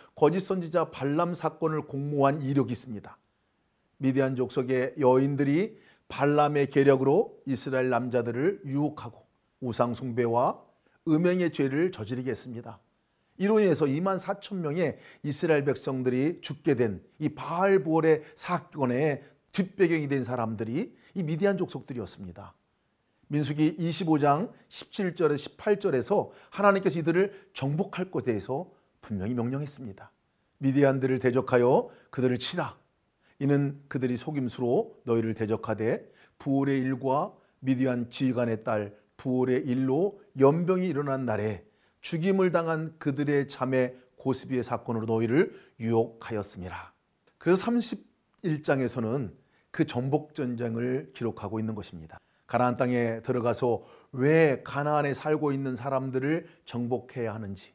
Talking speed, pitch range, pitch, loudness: 300 characters per minute, 120-155 Hz, 135 Hz, -28 LUFS